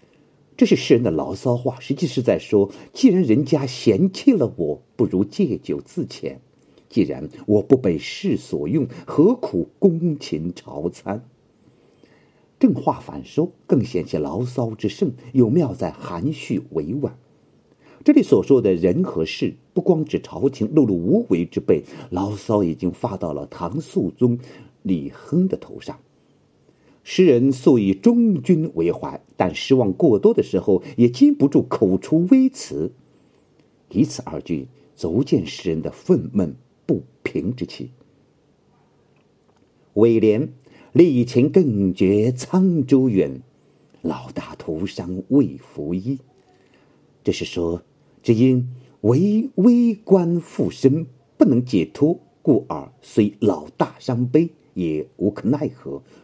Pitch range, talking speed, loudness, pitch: 100-160 Hz, 185 characters per minute, -20 LUFS, 130 Hz